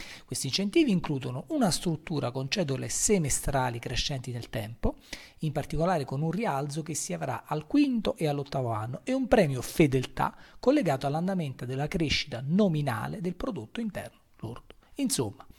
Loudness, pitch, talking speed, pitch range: -29 LUFS, 150 Hz, 145 wpm, 130-190 Hz